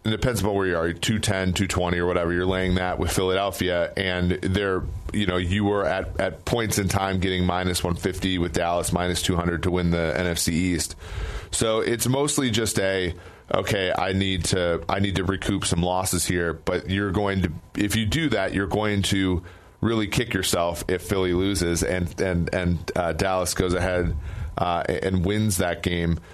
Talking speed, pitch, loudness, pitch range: 195 wpm, 95 Hz, -24 LUFS, 90-100 Hz